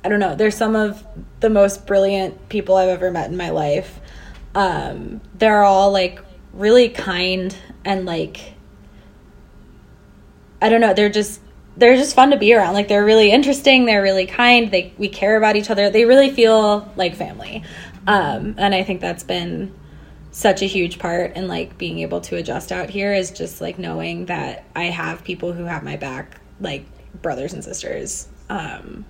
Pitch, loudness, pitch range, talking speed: 195 Hz, -17 LUFS, 175-215 Hz, 180 wpm